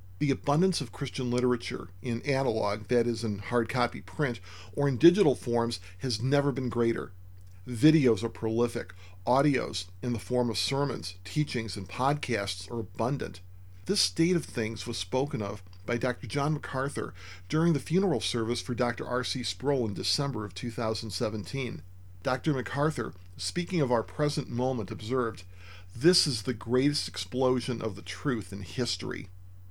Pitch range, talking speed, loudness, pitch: 100-135 Hz, 155 wpm, -29 LUFS, 120 Hz